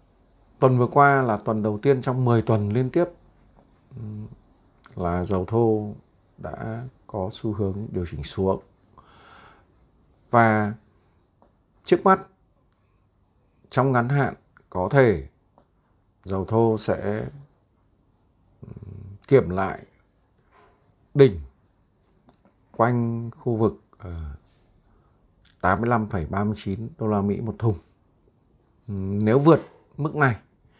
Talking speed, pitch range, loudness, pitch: 95 wpm, 95-120 Hz, -23 LUFS, 105 Hz